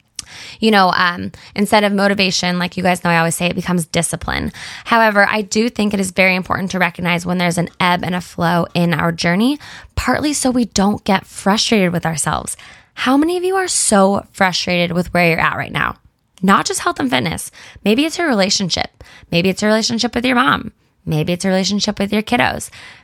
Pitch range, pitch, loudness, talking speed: 175-215 Hz, 190 Hz, -16 LUFS, 210 wpm